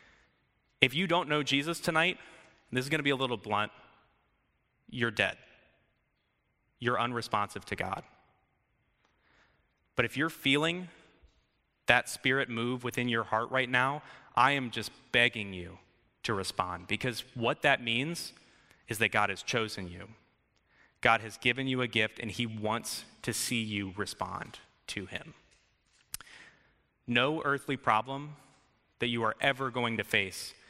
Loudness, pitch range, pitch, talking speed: -31 LUFS, 110-135 Hz, 120 Hz, 145 wpm